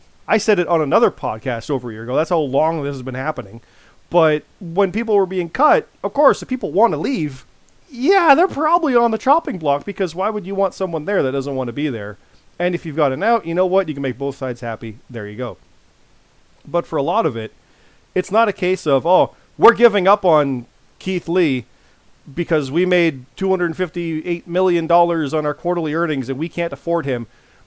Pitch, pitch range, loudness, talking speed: 170 Hz, 135-190 Hz, -18 LUFS, 215 wpm